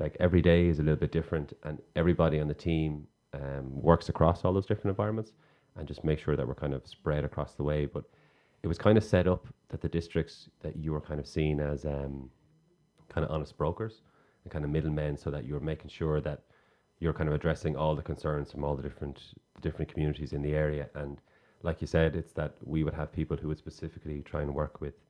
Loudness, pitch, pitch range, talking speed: -32 LUFS, 75 Hz, 75-85 Hz, 230 wpm